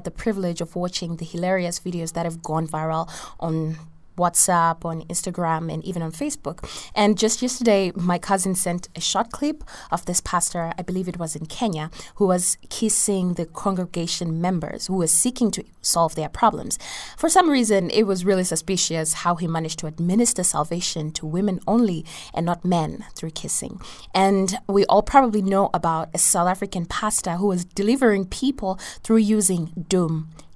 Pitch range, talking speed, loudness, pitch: 165-200 Hz, 175 wpm, -22 LUFS, 180 Hz